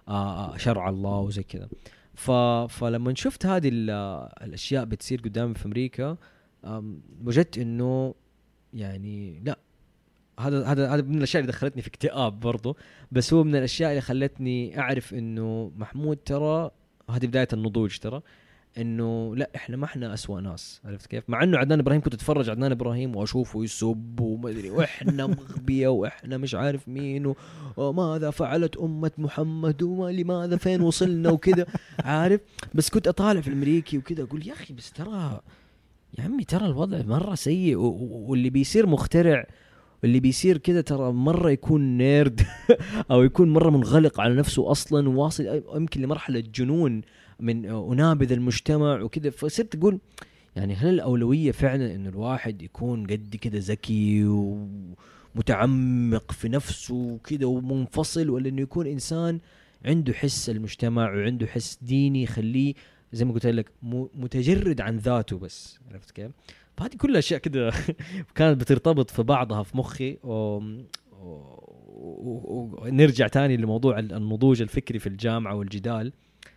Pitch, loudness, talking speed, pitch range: 130 Hz, -25 LUFS, 140 wpm, 115-150 Hz